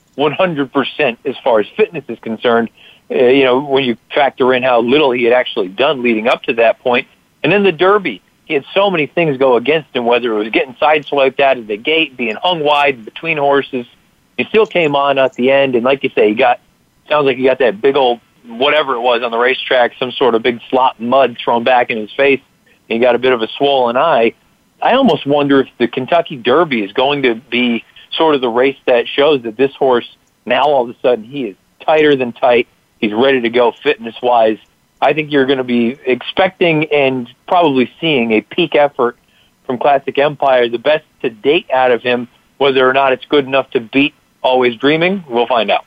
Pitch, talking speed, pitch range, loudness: 135 Hz, 220 wpm, 120-145 Hz, -13 LUFS